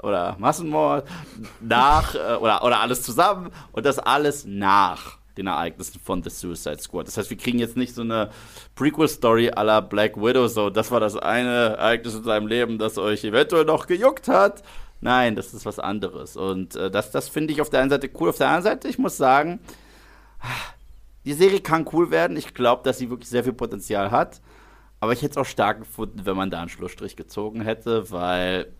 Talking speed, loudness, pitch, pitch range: 200 wpm, -22 LUFS, 115 Hz, 100-135 Hz